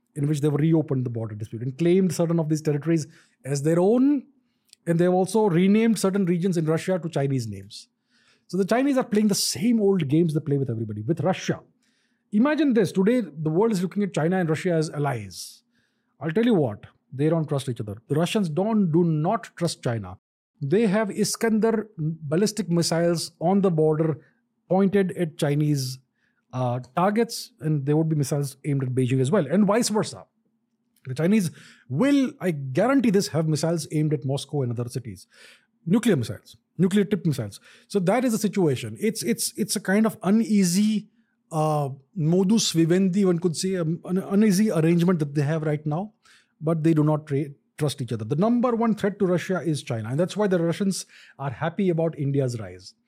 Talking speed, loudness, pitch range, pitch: 190 wpm, -24 LUFS, 150-210 Hz, 170 Hz